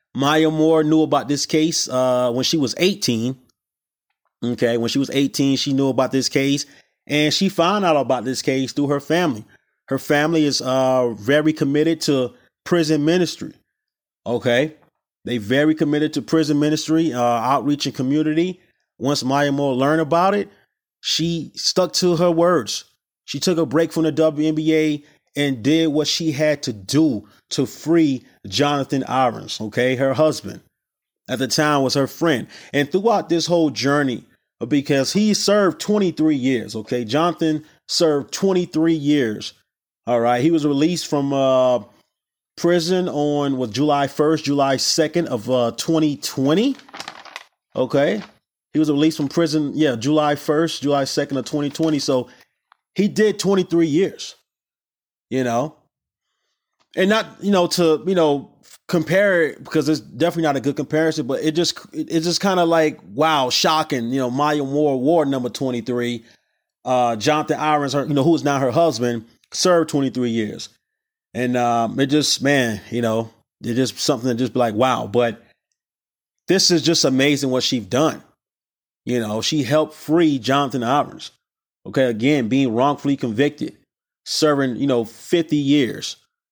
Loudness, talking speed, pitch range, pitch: -19 LUFS, 160 wpm, 130-160 Hz, 145 Hz